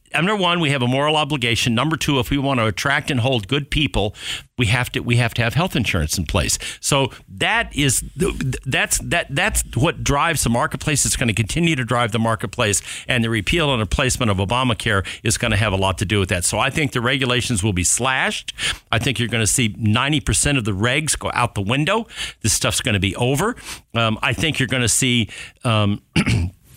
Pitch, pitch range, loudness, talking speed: 120 Hz, 110-140 Hz, -19 LUFS, 230 wpm